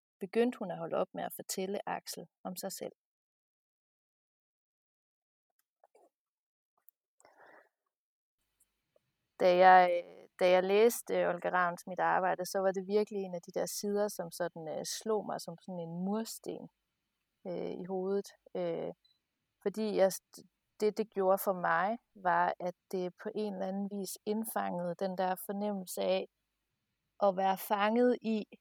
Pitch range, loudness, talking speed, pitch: 180-210 Hz, -33 LUFS, 140 wpm, 190 Hz